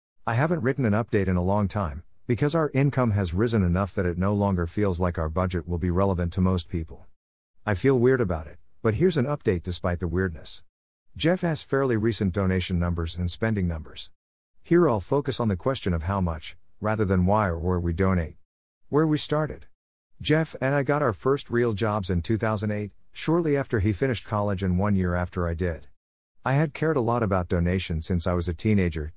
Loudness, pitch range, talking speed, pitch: -25 LUFS, 90-120 Hz, 210 wpm, 100 Hz